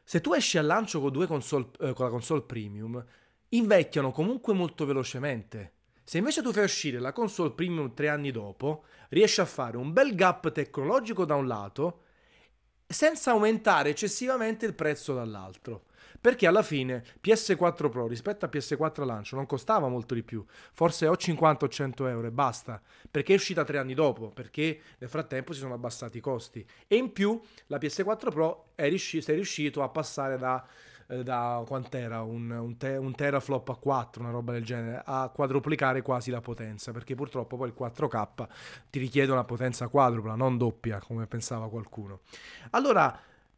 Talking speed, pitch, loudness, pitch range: 175 wpm, 140 Hz, -29 LUFS, 120-160 Hz